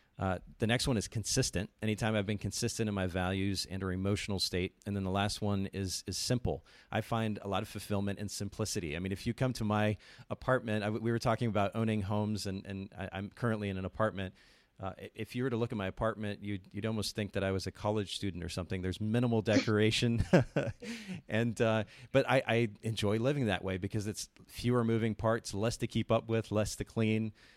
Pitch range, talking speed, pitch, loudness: 100-115 Hz, 230 wpm, 105 Hz, -34 LUFS